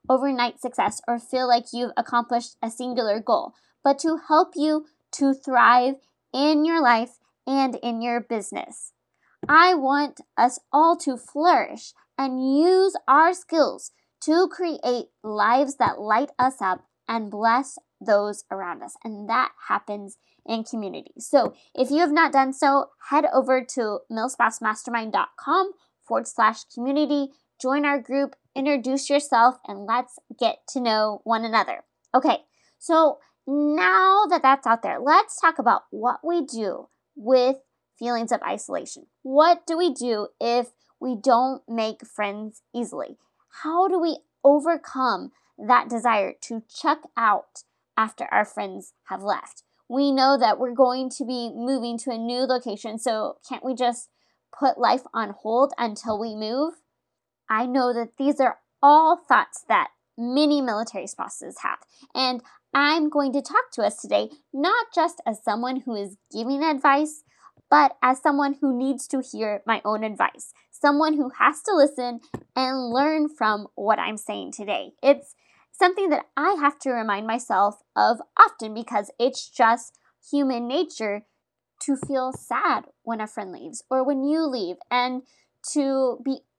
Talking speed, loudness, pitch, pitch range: 150 wpm, -23 LUFS, 260 Hz, 230-290 Hz